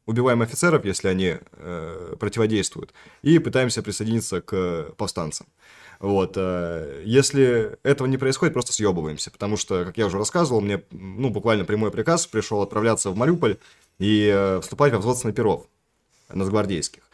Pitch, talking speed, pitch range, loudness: 110 Hz, 140 wpm, 100-125 Hz, -23 LUFS